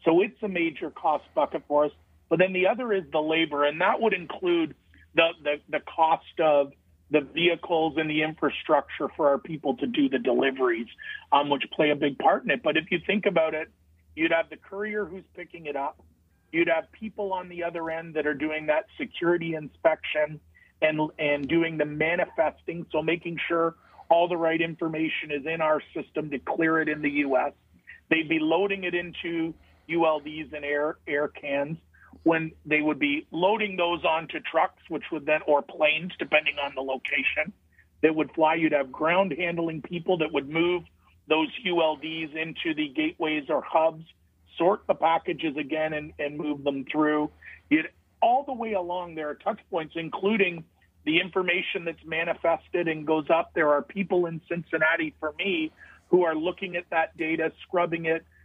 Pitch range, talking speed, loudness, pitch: 150-175 Hz, 185 wpm, -26 LUFS, 160 Hz